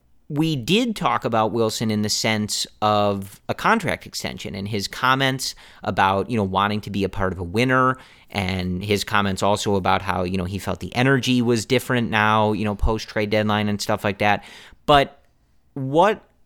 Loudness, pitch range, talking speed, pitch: -21 LUFS, 100-120 Hz, 190 wpm, 105 Hz